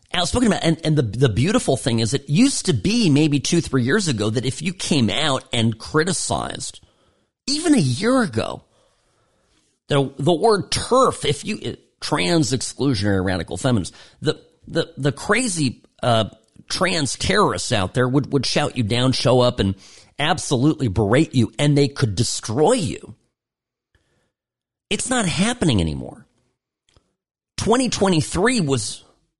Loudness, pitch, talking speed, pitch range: -20 LUFS, 135 Hz, 150 wpm, 115-165 Hz